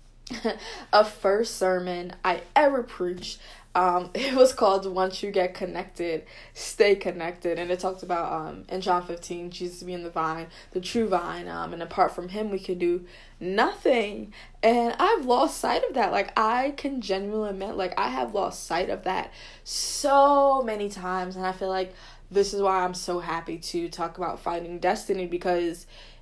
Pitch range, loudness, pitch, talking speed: 175-205 Hz, -26 LUFS, 185 Hz, 175 wpm